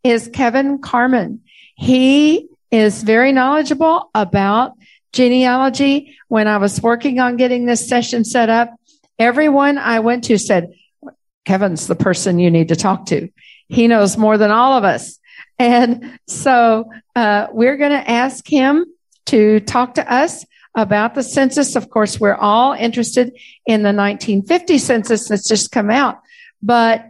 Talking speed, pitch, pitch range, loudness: 150 wpm, 240 Hz, 215-270 Hz, -14 LUFS